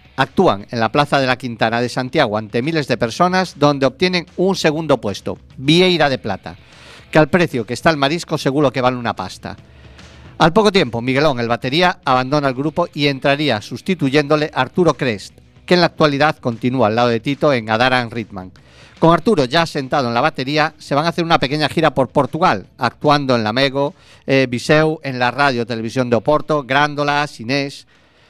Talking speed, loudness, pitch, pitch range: 190 wpm, -16 LUFS, 140 Hz, 120-155 Hz